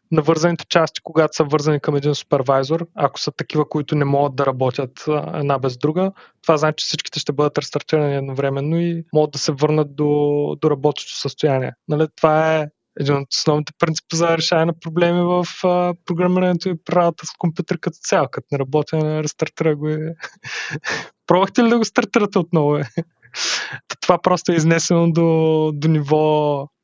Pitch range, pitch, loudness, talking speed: 145-170 Hz, 155 Hz, -19 LUFS, 170 wpm